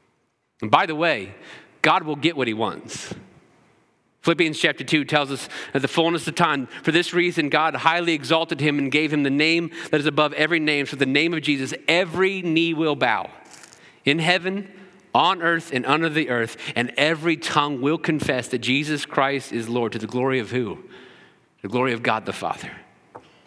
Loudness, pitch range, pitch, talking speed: -21 LUFS, 140-165 Hz, 155 Hz, 190 wpm